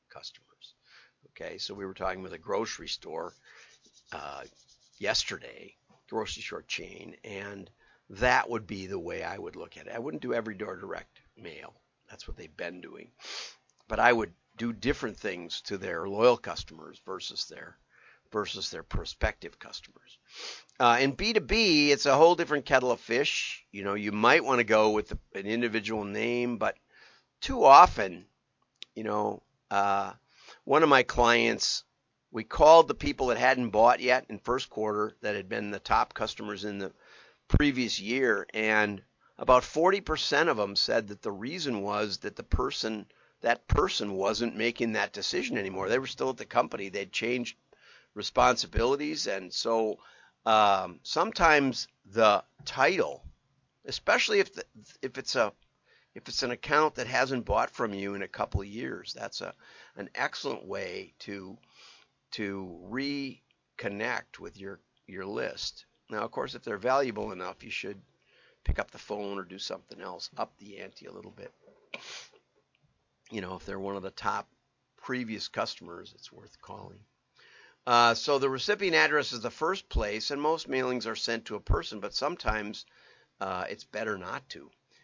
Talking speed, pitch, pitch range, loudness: 165 wpm, 115 Hz, 100-135 Hz, -28 LUFS